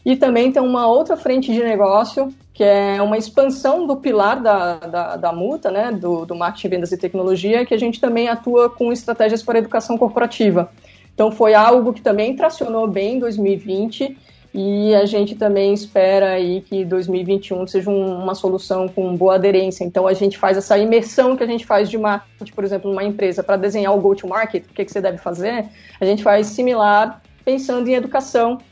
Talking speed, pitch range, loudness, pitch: 190 wpm, 195-235 Hz, -17 LUFS, 210 Hz